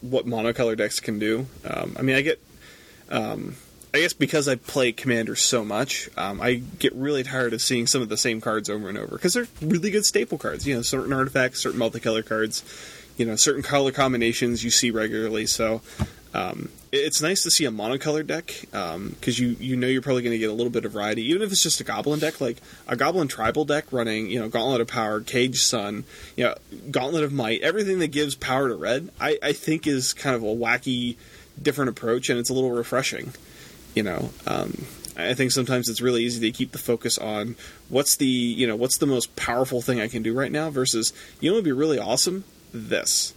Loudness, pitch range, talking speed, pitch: -24 LUFS, 115-140 Hz, 225 wpm, 125 Hz